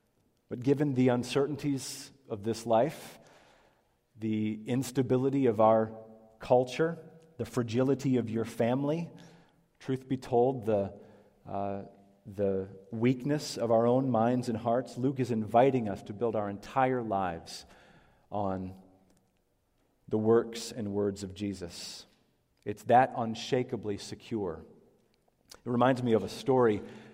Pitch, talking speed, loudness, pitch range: 115 Hz, 125 wpm, -30 LUFS, 105-130 Hz